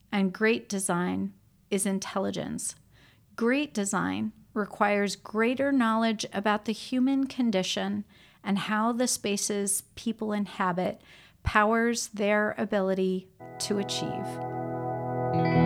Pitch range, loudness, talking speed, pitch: 195-225 Hz, -28 LUFS, 95 wpm, 210 Hz